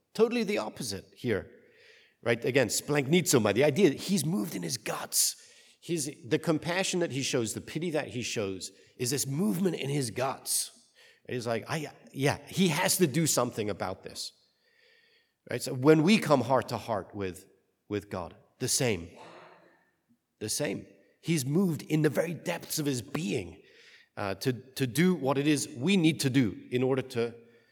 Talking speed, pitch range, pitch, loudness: 175 wpm, 120-175 Hz, 145 Hz, -29 LUFS